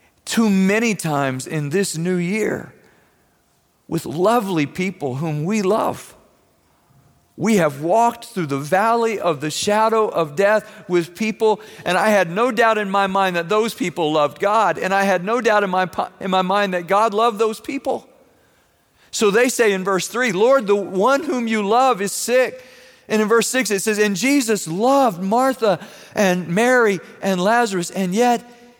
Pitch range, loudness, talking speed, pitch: 185-230 Hz, -19 LUFS, 175 wpm, 210 Hz